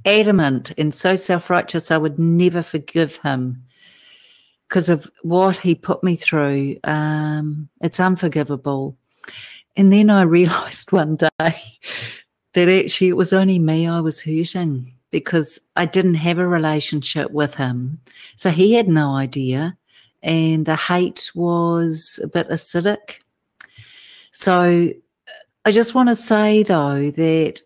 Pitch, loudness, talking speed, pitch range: 170 Hz, -18 LUFS, 135 wpm, 150-185 Hz